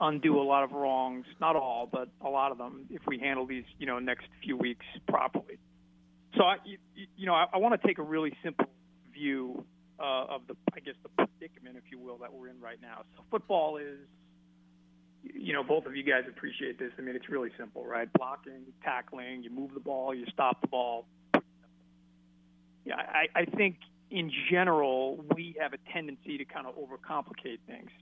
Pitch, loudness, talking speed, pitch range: 130 Hz, -32 LUFS, 200 wpm, 115-150 Hz